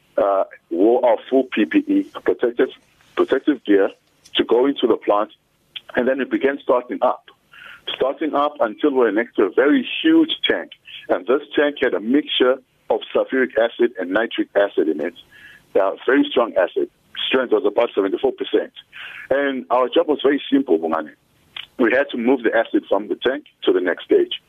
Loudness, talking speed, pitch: -19 LUFS, 175 wpm, 325 Hz